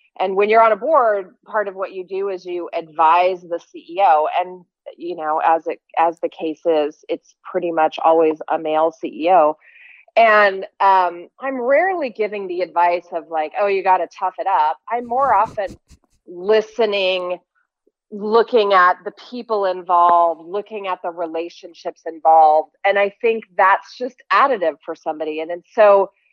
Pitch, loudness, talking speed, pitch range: 185 Hz, -18 LUFS, 165 wpm, 170-215 Hz